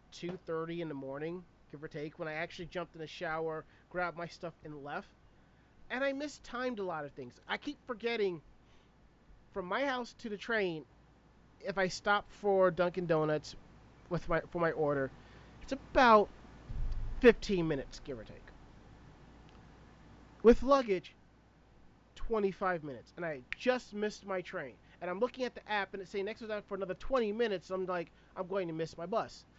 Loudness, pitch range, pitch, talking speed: -35 LUFS, 155-205 Hz, 180 Hz, 180 wpm